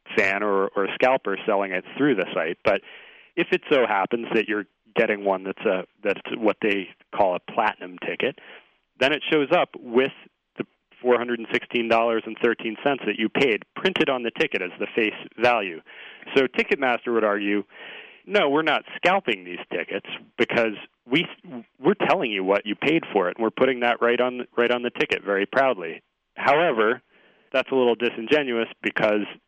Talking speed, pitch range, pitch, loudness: 200 wpm, 105-125 Hz, 115 Hz, -23 LUFS